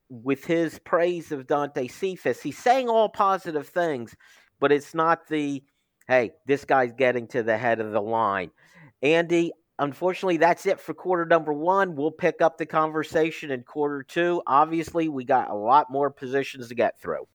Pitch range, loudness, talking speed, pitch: 135-170 Hz, -24 LUFS, 175 wpm, 155 Hz